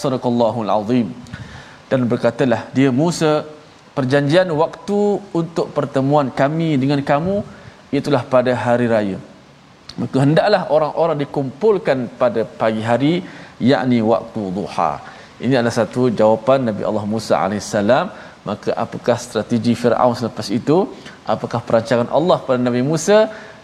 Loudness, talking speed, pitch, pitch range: -18 LUFS, 120 wpm, 135 Hz, 120-155 Hz